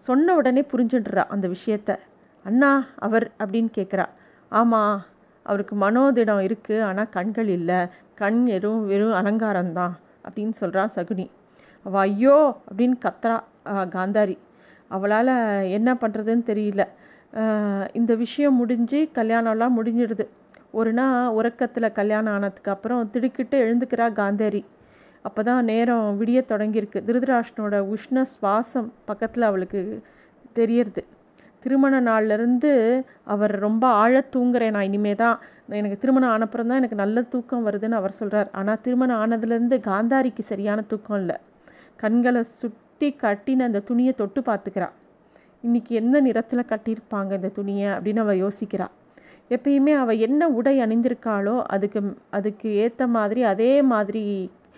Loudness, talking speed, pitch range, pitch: -22 LUFS, 120 wpm, 205-245 Hz, 225 Hz